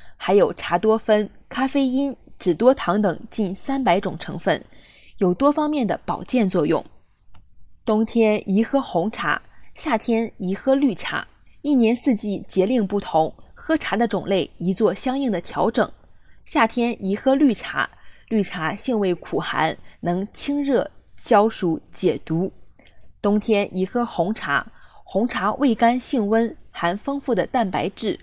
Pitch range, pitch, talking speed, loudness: 185-250 Hz, 215 Hz, 205 characters per minute, -21 LUFS